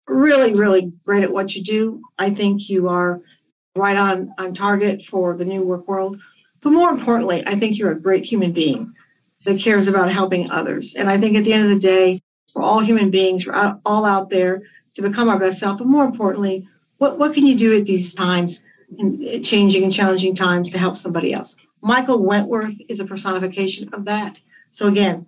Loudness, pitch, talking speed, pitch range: -18 LUFS, 195 Hz, 205 wpm, 185-215 Hz